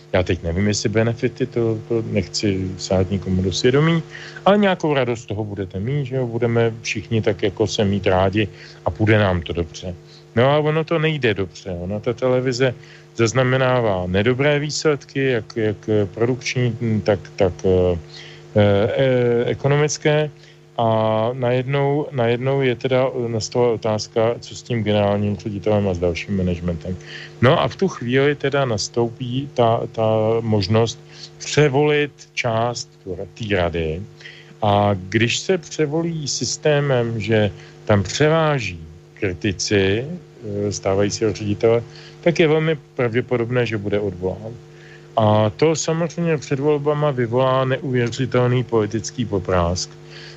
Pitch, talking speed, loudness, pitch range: 120 Hz, 130 wpm, -20 LUFS, 105-145 Hz